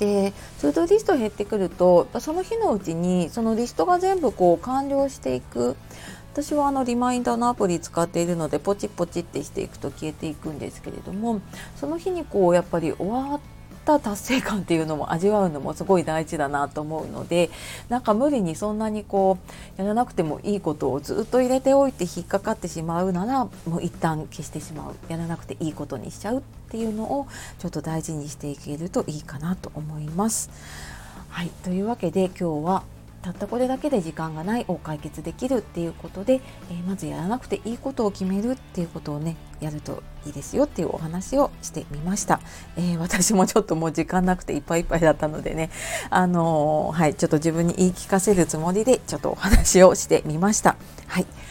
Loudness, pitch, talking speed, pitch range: -24 LUFS, 180 Hz, 425 characters per minute, 160-220 Hz